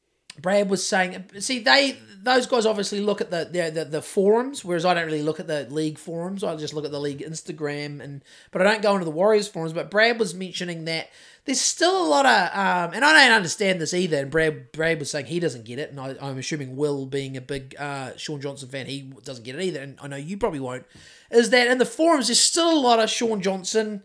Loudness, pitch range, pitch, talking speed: -22 LUFS, 145-220 Hz, 175 Hz, 250 wpm